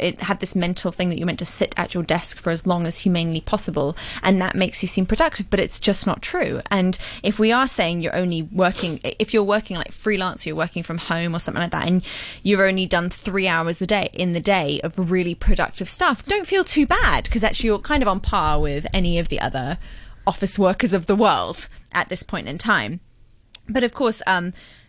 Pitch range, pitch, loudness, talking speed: 170-205 Hz, 185 Hz, -21 LUFS, 235 wpm